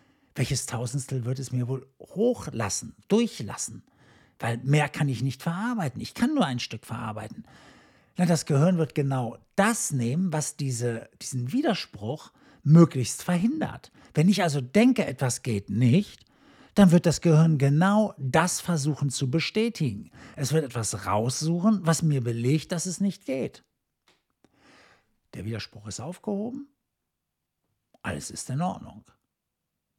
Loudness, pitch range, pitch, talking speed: -26 LUFS, 125-180 Hz, 150 Hz, 135 wpm